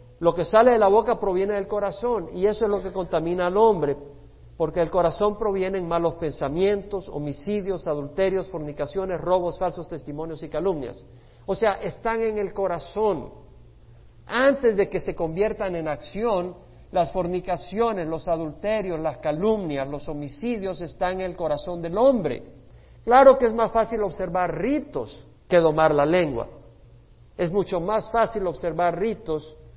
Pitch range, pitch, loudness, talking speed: 160-205 Hz, 180 Hz, -24 LUFS, 150 wpm